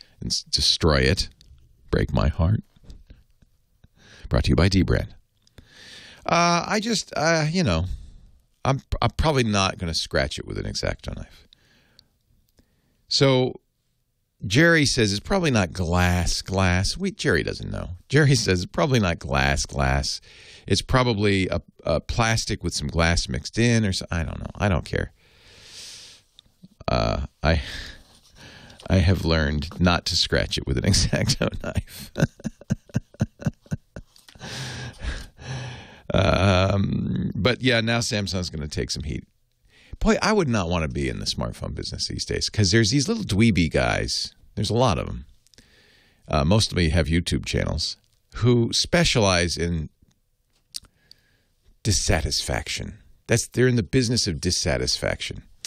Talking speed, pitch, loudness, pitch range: 140 wpm, 95 Hz, -23 LUFS, 80-115 Hz